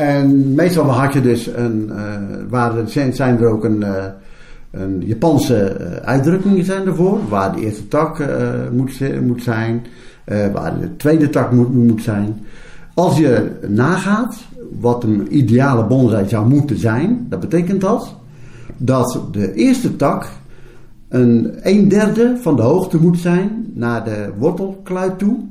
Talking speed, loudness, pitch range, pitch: 150 wpm, -16 LUFS, 115-170 Hz, 125 Hz